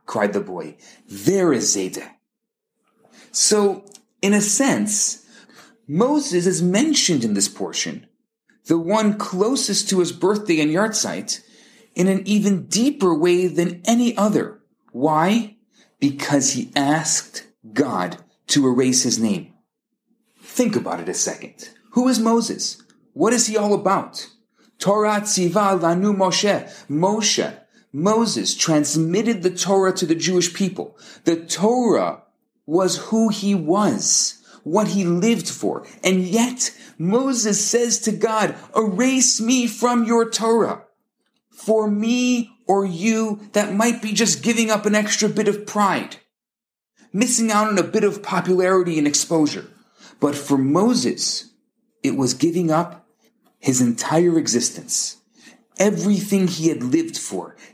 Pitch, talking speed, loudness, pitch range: 210 Hz, 130 wpm, -19 LUFS, 180-230 Hz